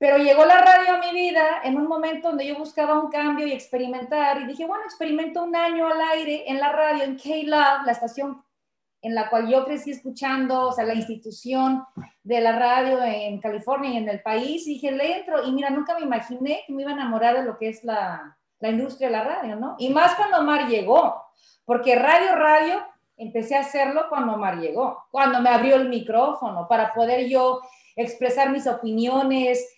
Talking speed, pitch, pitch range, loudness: 205 wpm, 270 Hz, 240-300 Hz, -22 LUFS